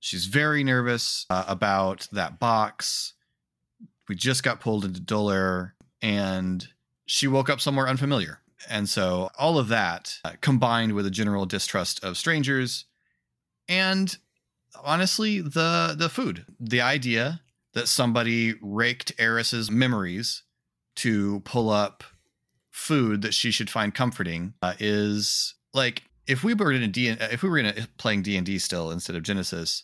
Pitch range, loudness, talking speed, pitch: 100-135 Hz, -25 LUFS, 150 wpm, 115 Hz